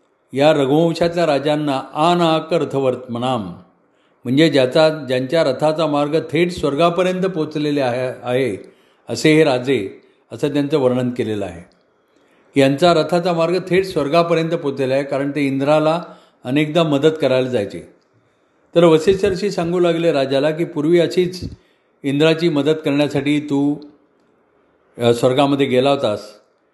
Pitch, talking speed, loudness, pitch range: 145 Hz, 115 wpm, -17 LUFS, 135-165 Hz